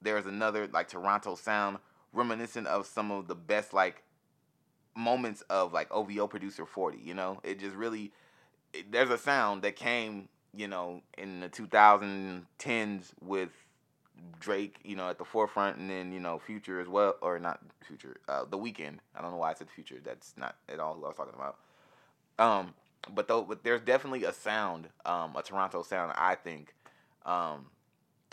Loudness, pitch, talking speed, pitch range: -33 LUFS, 100 Hz, 180 wpm, 95-110 Hz